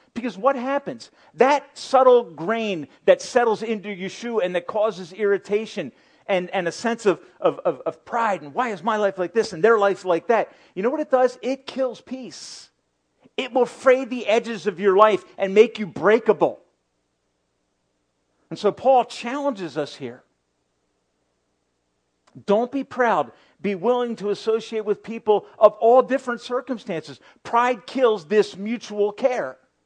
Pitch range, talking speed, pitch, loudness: 185-245 Hz, 160 wpm, 215 Hz, -22 LUFS